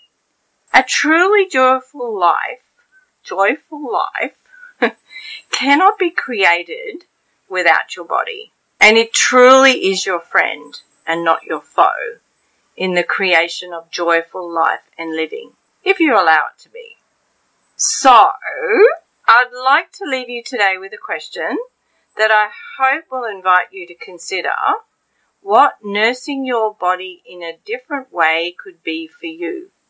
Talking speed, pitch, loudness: 130 wpm, 255 Hz, -15 LUFS